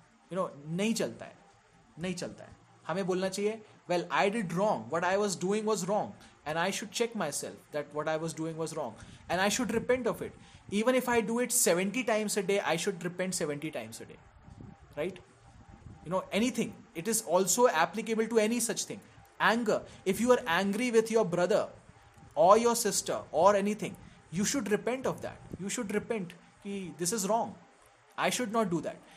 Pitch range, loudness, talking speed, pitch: 170-225 Hz, -31 LUFS, 205 wpm, 200 Hz